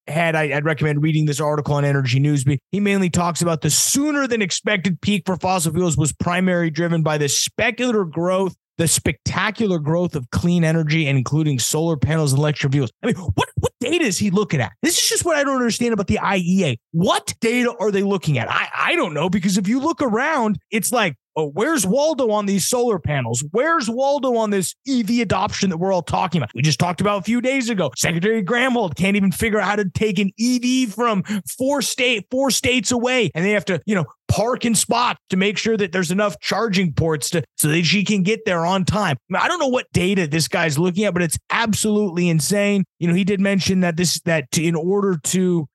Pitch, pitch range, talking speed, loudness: 190 Hz, 160-220 Hz, 225 wpm, -19 LUFS